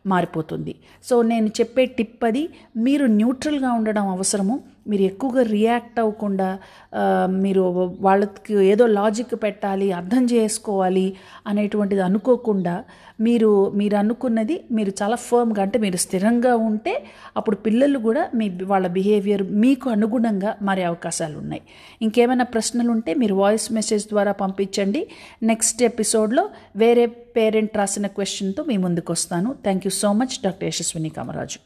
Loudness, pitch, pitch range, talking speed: -21 LUFS, 215 Hz, 195-235 Hz, 130 wpm